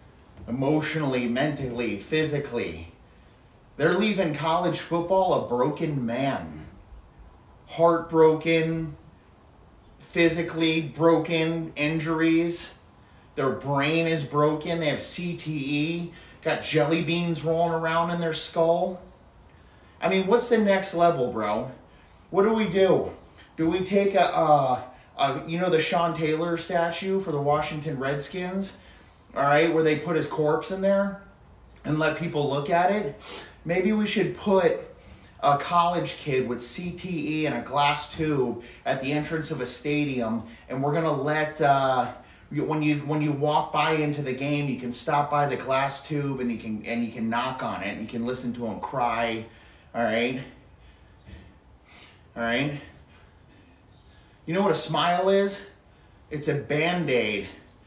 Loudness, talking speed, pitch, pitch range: -25 LUFS, 140 wpm, 150 Hz, 120-165 Hz